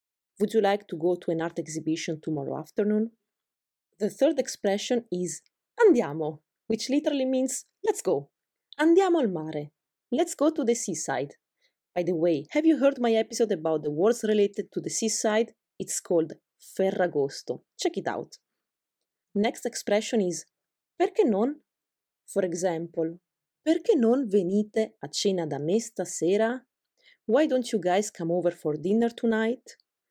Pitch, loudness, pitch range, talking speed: 210 Hz, -27 LUFS, 175-245 Hz, 145 wpm